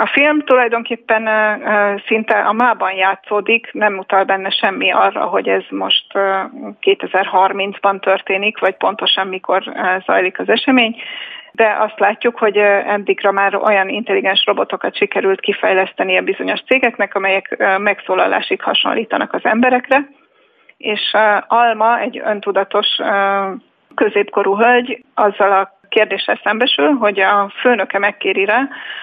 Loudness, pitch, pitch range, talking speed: -15 LUFS, 210 Hz, 195-240 Hz, 120 wpm